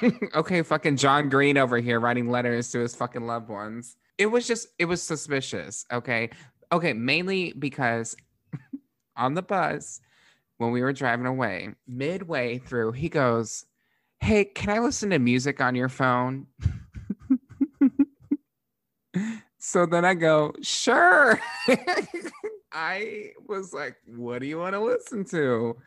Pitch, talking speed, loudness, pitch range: 145 Hz, 135 wpm, -25 LUFS, 120-200 Hz